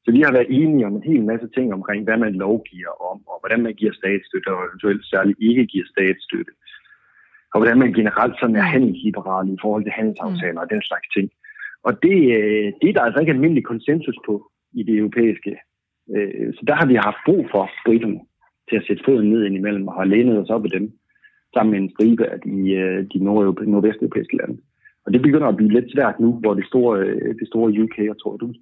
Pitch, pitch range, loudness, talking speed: 110 Hz, 100-115 Hz, -19 LUFS, 215 wpm